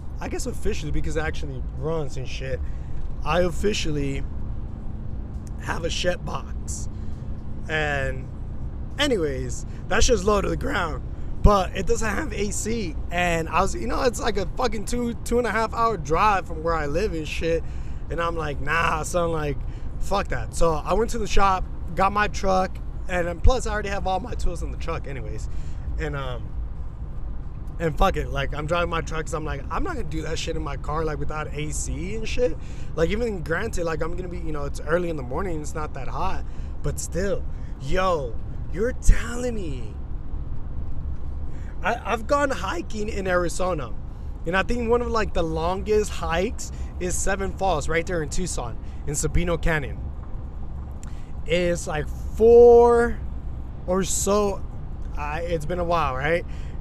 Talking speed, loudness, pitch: 175 wpm, -25 LUFS, 160 Hz